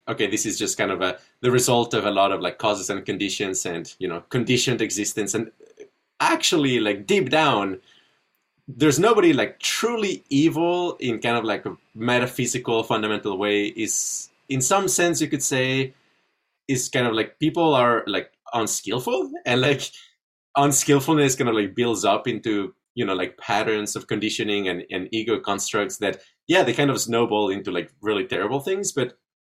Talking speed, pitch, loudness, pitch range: 175 wpm, 130 Hz, -22 LUFS, 110-155 Hz